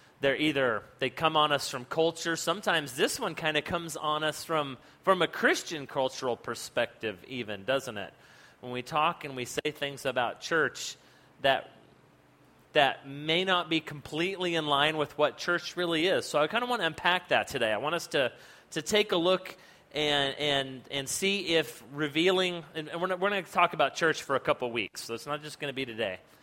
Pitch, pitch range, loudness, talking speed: 155 Hz, 140-175 Hz, -29 LUFS, 205 wpm